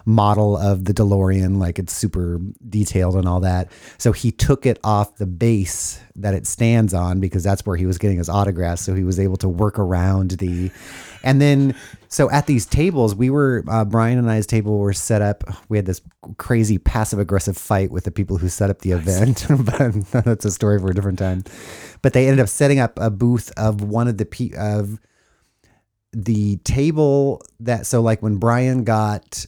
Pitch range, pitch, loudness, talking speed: 95-115 Hz, 105 Hz, -19 LUFS, 200 wpm